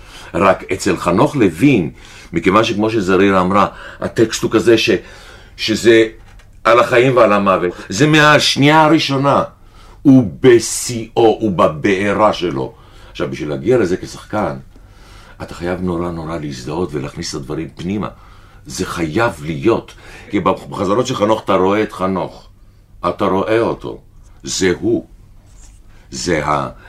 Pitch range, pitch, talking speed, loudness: 95-115 Hz, 100 Hz, 130 wpm, -15 LUFS